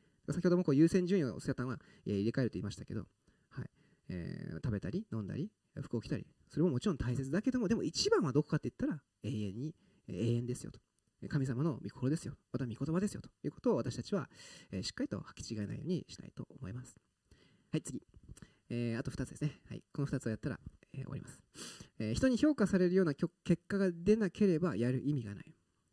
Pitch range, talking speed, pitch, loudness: 115-180 Hz, 430 characters per minute, 140 Hz, -36 LUFS